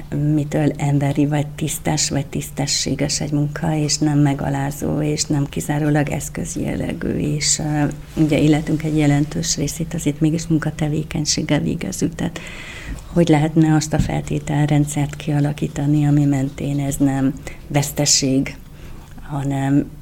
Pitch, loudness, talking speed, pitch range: 150 Hz, -19 LUFS, 120 wpm, 145-155 Hz